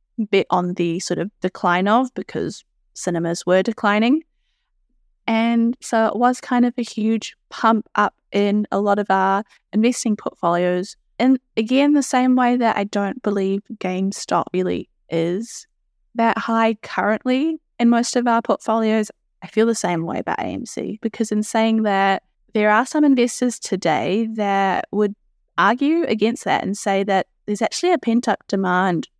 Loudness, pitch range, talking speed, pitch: -20 LUFS, 195-240 Hz, 160 wpm, 220 Hz